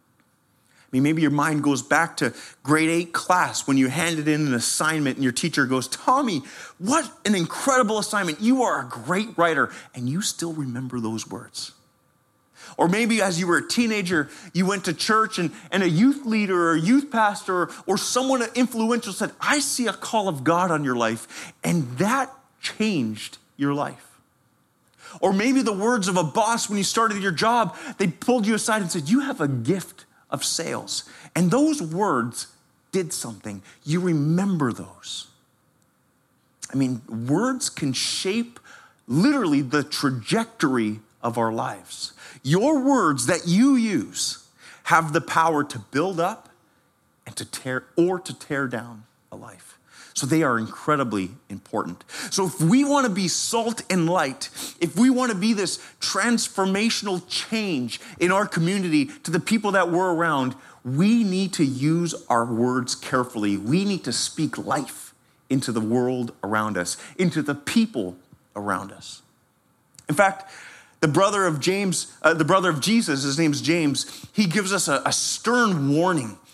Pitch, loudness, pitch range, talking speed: 175 Hz, -23 LUFS, 140-210 Hz, 165 wpm